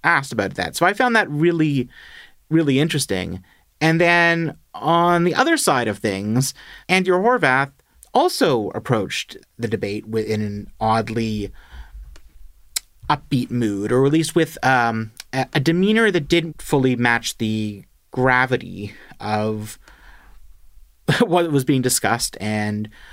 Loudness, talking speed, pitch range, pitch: -20 LUFS, 125 wpm, 105-160 Hz, 125 Hz